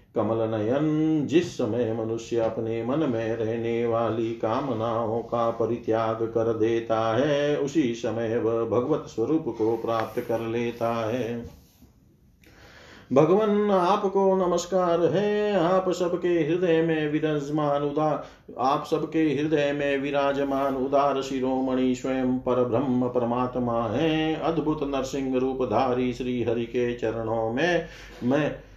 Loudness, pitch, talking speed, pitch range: -25 LUFS, 130 Hz, 125 wpm, 115-155 Hz